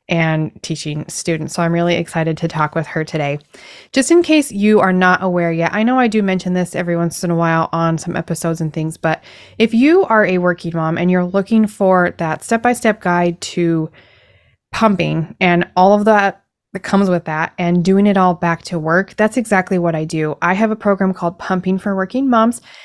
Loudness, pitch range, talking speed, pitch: -16 LUFS, 165-200 Hz, 220 wpm, 175 Hz